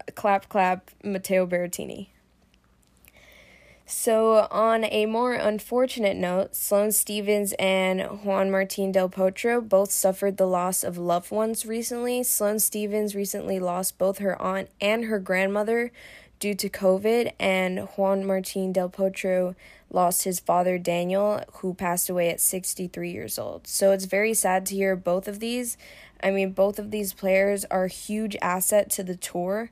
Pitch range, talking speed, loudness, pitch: 185-210 Hz, 155 wpm, -25 LUFS, 195 Hz